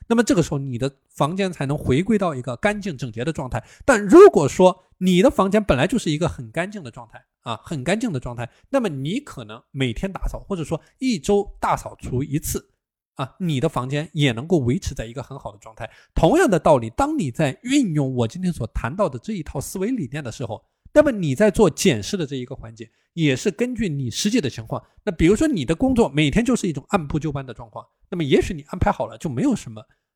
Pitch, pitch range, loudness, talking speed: 155 Hz, 130-205 Hz, -21 LUFS, 345 characters per minute